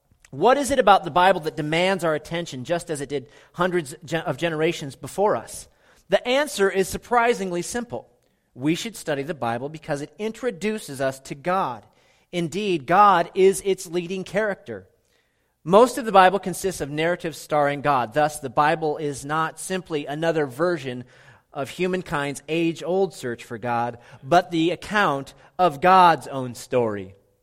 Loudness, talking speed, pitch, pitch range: -22 LUFS, 160 wpm, 165 Hz, 145-185 Hz